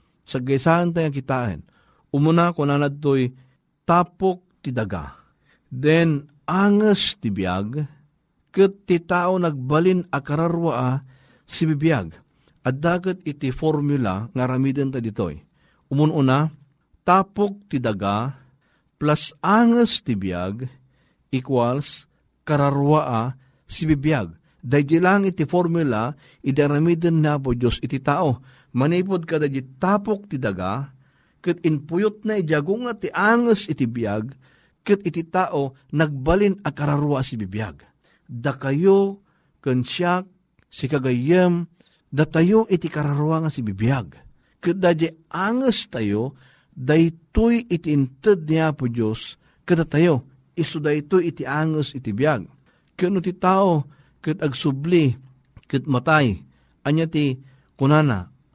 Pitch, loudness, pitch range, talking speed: 150 Hz, -21 LUFS, 130-170 Hz, 115 wpm